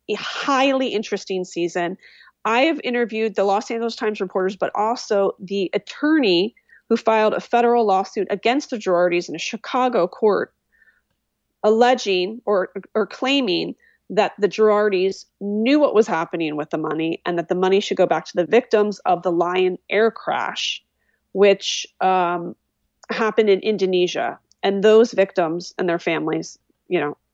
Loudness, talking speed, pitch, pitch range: -20 LUFS, 155 wpm, 200 Hz, 180-225 Hz